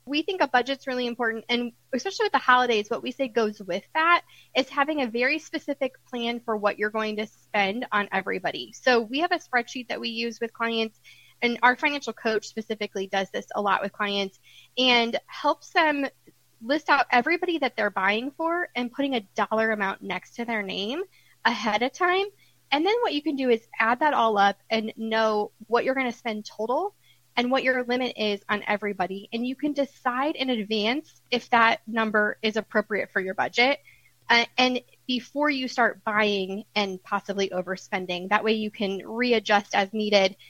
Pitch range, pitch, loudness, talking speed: 210-265 Hz, 235 Hz, -25 LUFS, 195 wpm